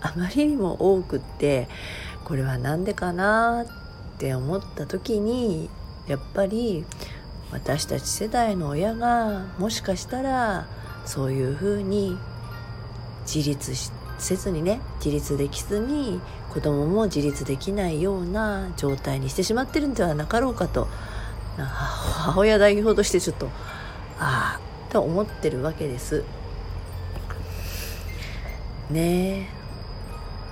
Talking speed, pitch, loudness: 225 characters per minute, 155 Hz, -25 LUFS